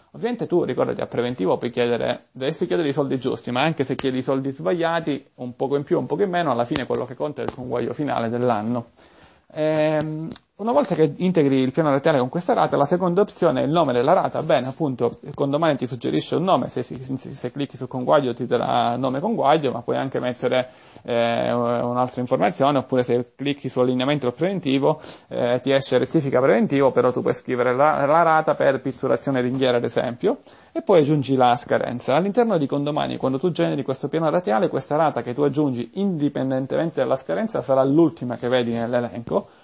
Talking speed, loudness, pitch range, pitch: 200 wpm, -22 LUFS, 125-155 Hz, 135 Hz